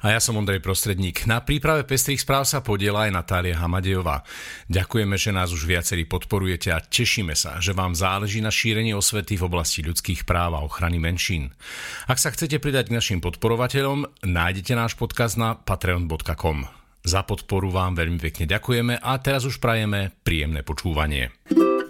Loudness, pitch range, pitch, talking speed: -23 LUFS, 85-115 Hz, 95 Hz, 165 wpm